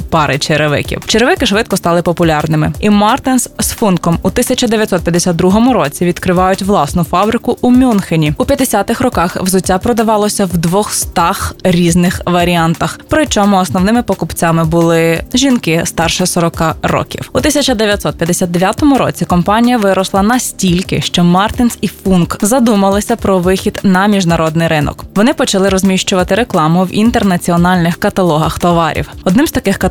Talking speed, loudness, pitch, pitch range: 125 wpm, -11 LUFS, 190 Hz, 175-220 Hz